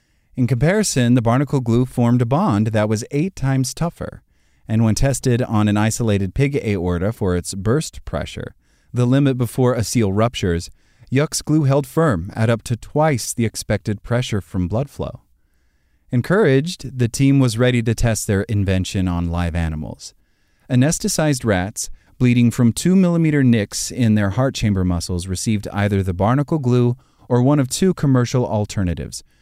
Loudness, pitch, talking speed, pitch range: -19 LUFS, 115 Hz, 165 wpm, 100-130 Hz